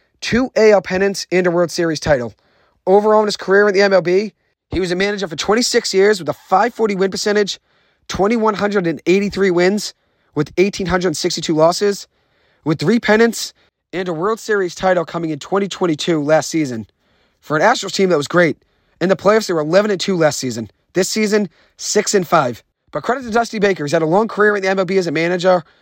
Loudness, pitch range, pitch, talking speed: -16 LUFS, 170-205 Hz, 190 Hz, 190 wpm